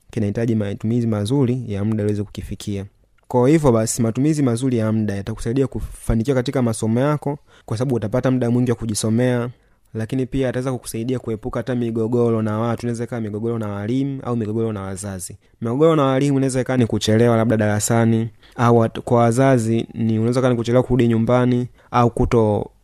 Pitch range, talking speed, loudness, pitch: 110-125 Hz, 165 wpm, -20 LUFS, 115 Hz